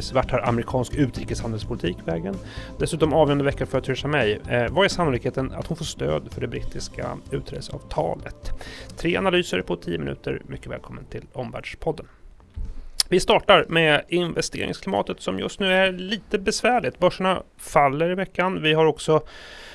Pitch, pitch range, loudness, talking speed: 145 Hz, 120-180 Hz, -23 LUFS, 150 wpm